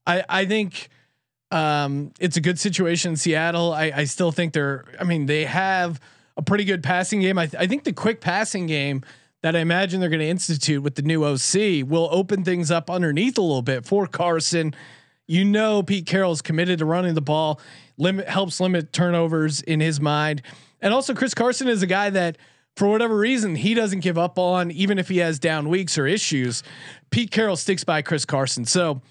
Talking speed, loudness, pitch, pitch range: 205 wpm, -22 LUFS, 170 Hz, 155-190 Hz